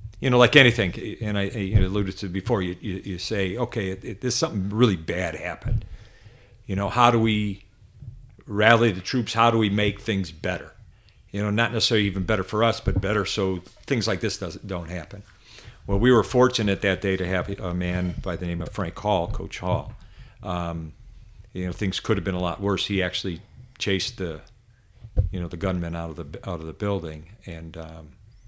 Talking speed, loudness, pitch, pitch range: 200 wpm, -24 LUFS, 100 Hz, 90-110 Hz